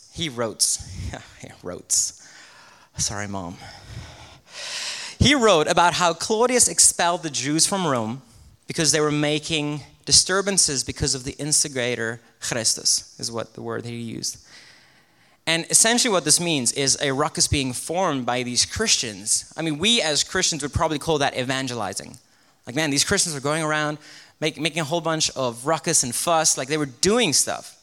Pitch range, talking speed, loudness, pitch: 125-165 Hz, 165 wpm, -21 LUFS, 150 Hz